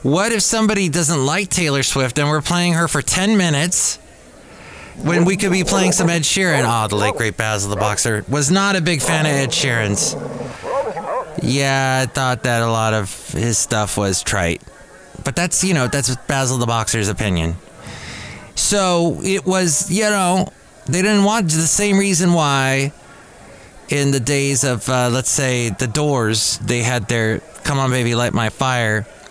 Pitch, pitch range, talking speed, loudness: 140 Hz, 115-175 Hz, 180 wpm, -17 LUFS